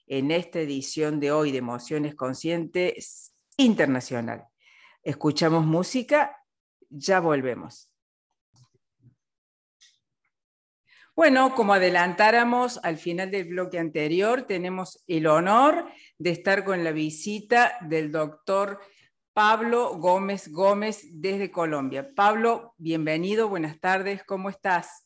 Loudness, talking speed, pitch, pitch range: -24 LUFS, 100 wpm, 180 Hz, 155-200 Hz